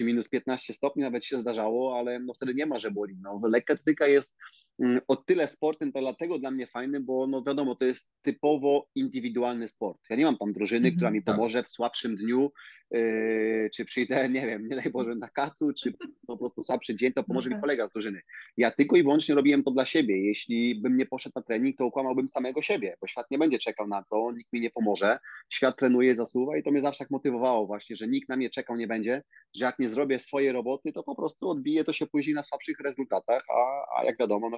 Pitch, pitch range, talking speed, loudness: 130 Hz, 115-140 Hz, 225 wpm, -28 LUFS